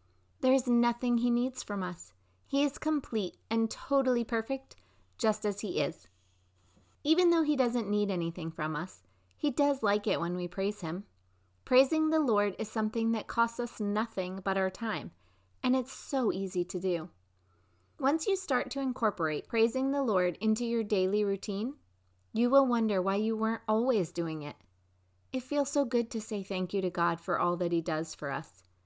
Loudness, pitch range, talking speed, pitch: -31 LUFS, 165-240 Hz, 185 wpm, 205 Hz